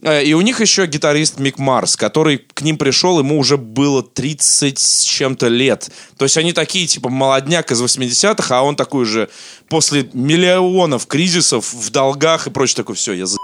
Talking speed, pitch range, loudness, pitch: 185 wpm, 130-160 Hz, -14 LUFS, 140 Hz